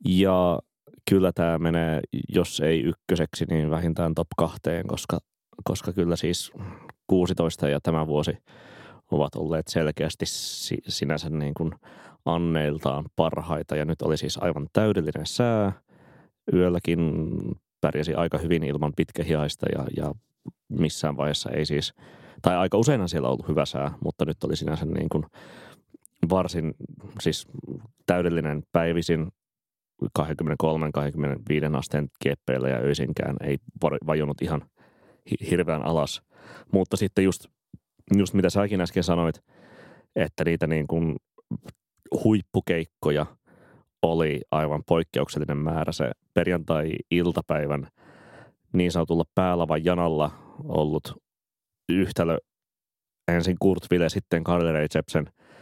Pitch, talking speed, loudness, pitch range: 80 Hz, 110 wpm, -26 LUFS, 75-90 Hz